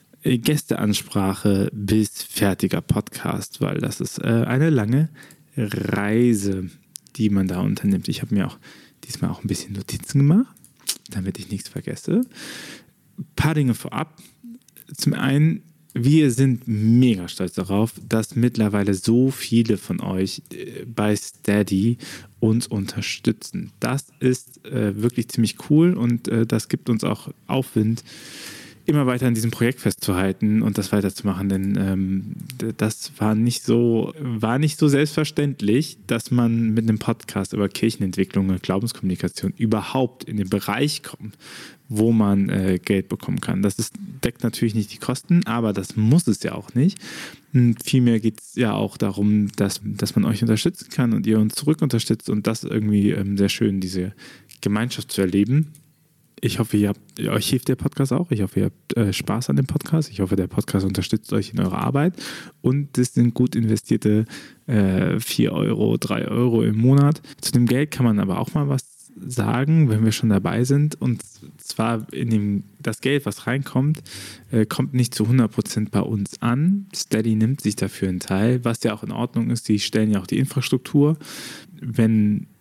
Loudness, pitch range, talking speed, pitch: -22 LUFS, 105-140 Hz, 165 wpm, 115 Hz